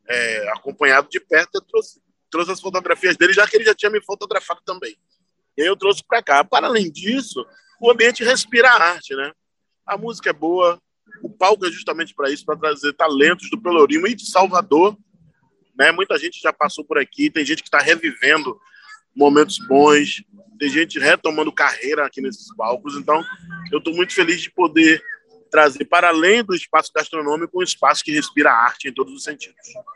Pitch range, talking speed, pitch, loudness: 160-255 Hz, 190 wpm, 190 Hz, -17 LUFS